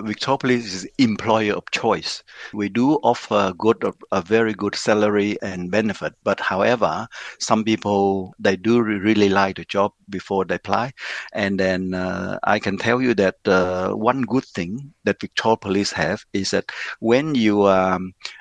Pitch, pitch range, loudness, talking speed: 100 Hz, 95-110 Hz, -21 LUFS, 165 wpm